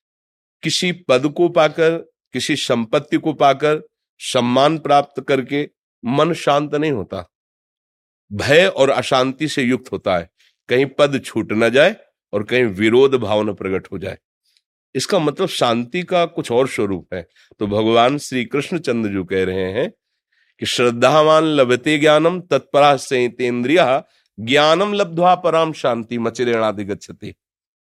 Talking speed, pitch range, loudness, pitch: 135 wpm, 115-155 Hz, -17 LUFS, 135 Hz